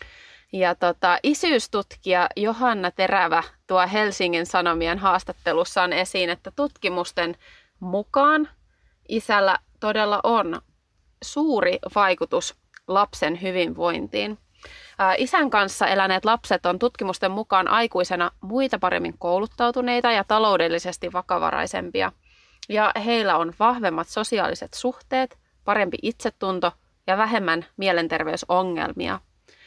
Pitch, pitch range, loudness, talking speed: 190 Hz, 180-225 Hz, -22 LUFS, 90 wpm